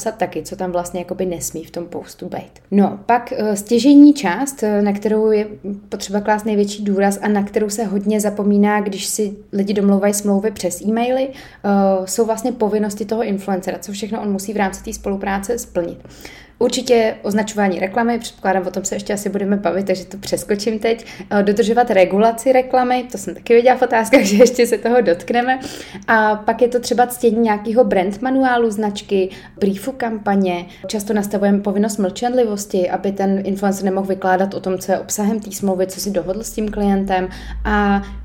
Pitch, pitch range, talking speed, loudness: 205 Hz, 195-230 Hz, 175 wpm, -17 LUFS